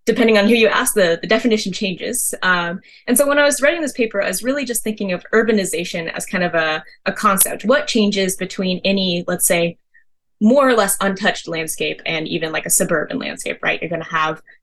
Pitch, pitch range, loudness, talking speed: 200 Hz, 180-235 Hz, -17 LUFS, 215 wpm